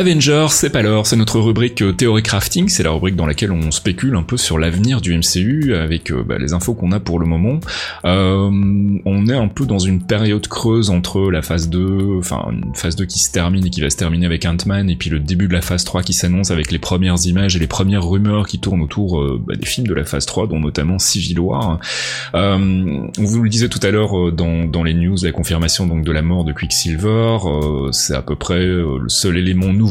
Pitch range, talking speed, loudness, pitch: 85-105 Hz, 245 wpm, -16 LUFS, 90 Hz